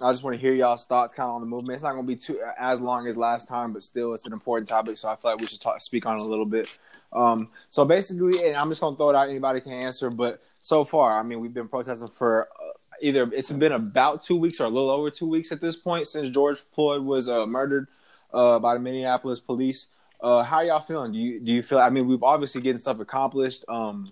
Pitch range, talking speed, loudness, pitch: 120-140 Hz, 270 wpm, -25 LUFS, 125 Hz